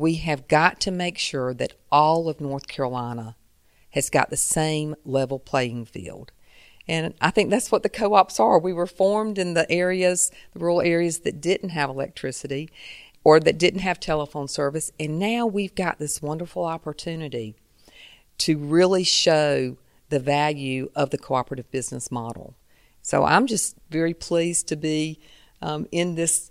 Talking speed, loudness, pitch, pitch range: 165 wpm, -23 LUFS, 155 Hz, 140-175 Hz